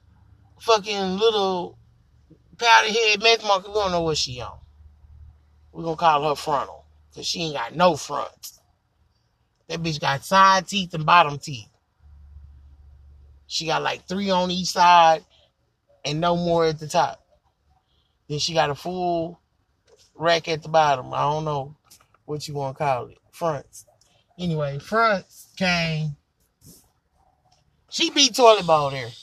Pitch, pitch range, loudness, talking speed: 155 Hz, 110-175 Hz, -21 LUFS, 150 wpm